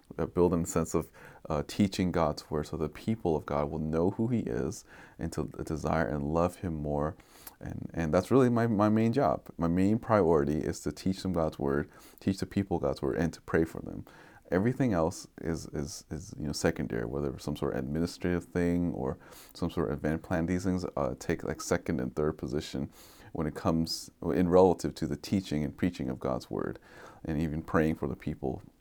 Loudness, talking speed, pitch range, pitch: -31 LUFS, 210 wpm, 75-90 Hz, 80 Hz